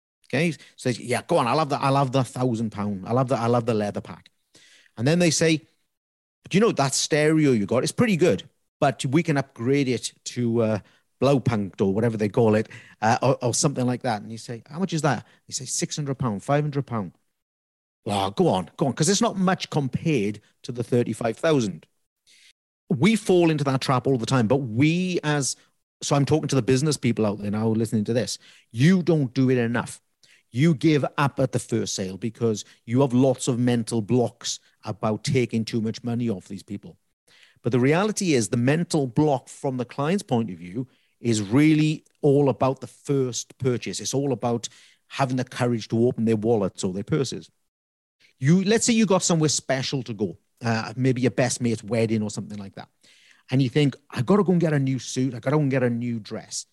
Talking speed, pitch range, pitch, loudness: 220 wpm, 115-145 Hz, 130 Hz, -23 LUFS